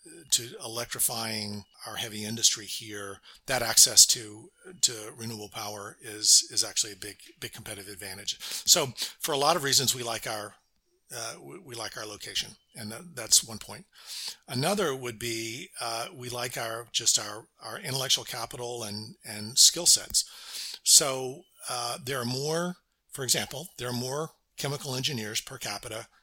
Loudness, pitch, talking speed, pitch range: -26 LUFS, 115 Hz, 160 wpm, 105-130 Hz